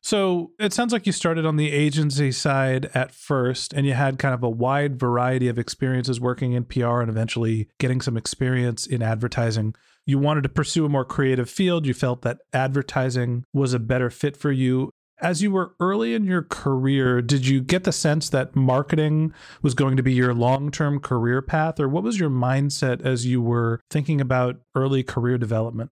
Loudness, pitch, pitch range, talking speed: -23 LUFS, 135 Hz, 125-150 Hz, 200 wpm